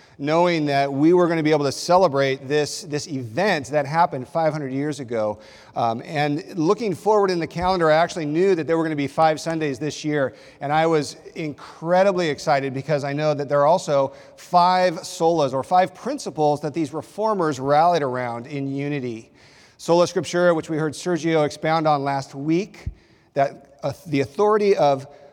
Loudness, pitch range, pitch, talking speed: -21 LUFS, 140-175 Hz, 155 Hz, 180 wpm